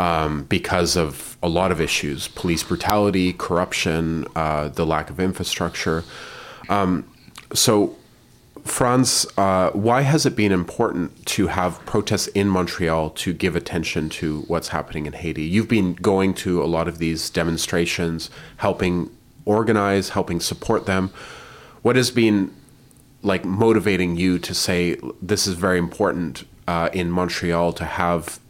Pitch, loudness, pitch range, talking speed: 90 Hz, -21 LUFS, 85-105 Hz, 145 wpm